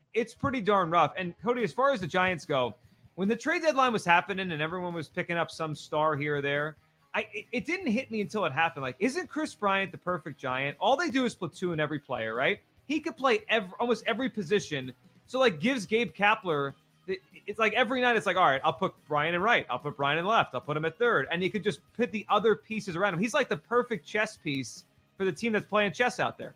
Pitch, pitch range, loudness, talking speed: 195 Hz, 155-230 Hz, -29 LUFS, 250 wpm